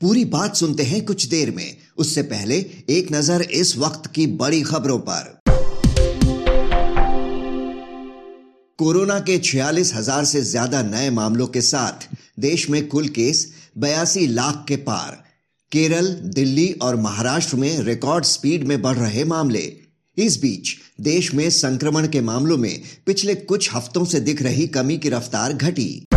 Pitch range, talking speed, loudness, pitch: 130-165 Hz, 145 wpm, -20 LUFS, 150 Hz